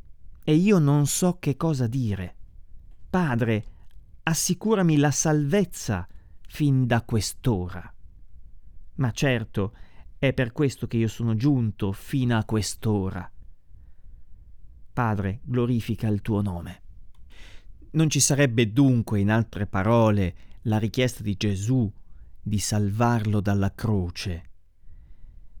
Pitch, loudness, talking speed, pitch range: 105 Hz, -24 LUFS, 110 wpm, 90-125 Hz